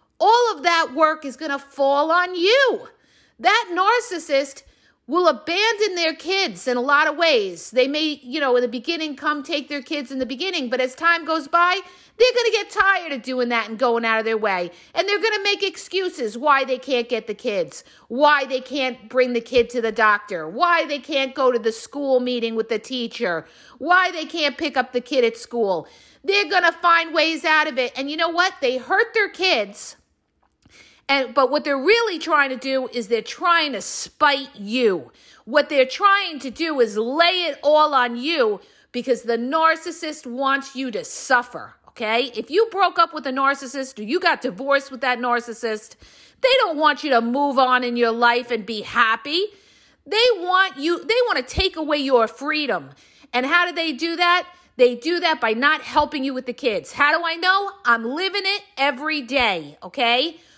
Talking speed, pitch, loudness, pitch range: 200 wpm, 290 Hz, -20 LUFS, 250-345 Hz